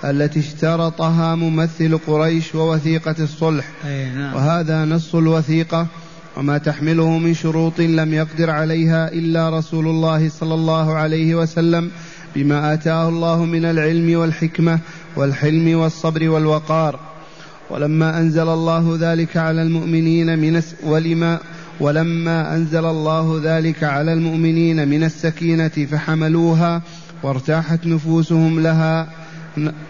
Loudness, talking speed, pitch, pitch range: -17 LUFS, 100 wpm, 160 Hz, 155-165 Hz